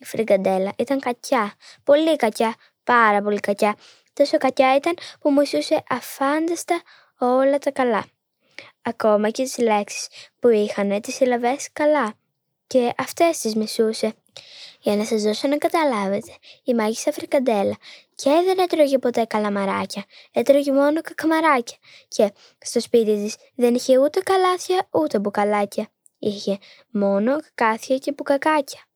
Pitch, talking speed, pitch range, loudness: 255 Hz, 130 wpm, 215-290 Hz, -21 LUFS